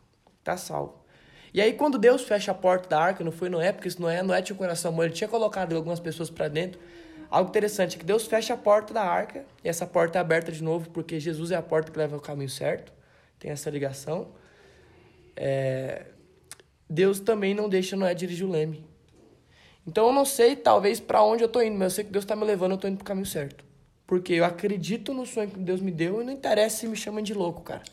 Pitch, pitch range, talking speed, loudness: 180 Hz, 160-210 Hz, 240 wpm, -26 LUFS